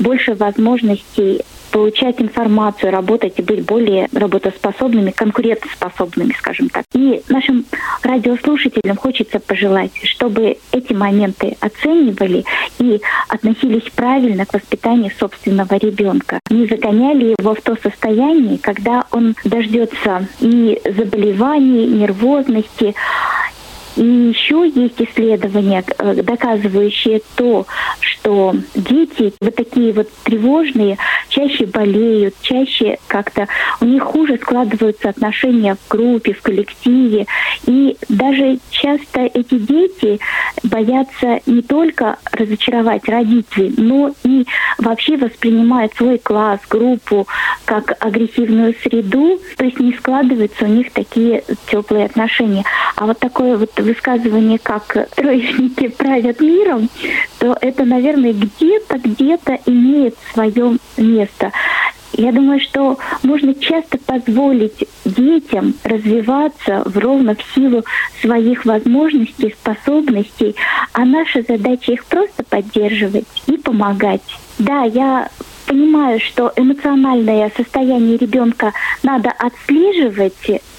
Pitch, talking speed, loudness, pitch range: 235 Hz, 105 wpm, -14 LUFS, 215-265 Hz